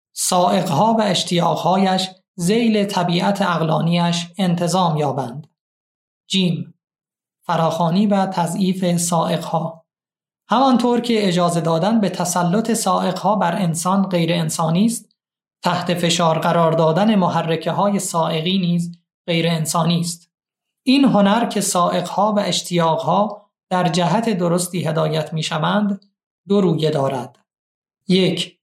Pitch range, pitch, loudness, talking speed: 165-200 Hz, 175 Hz, -18 LUFS, 105 wpm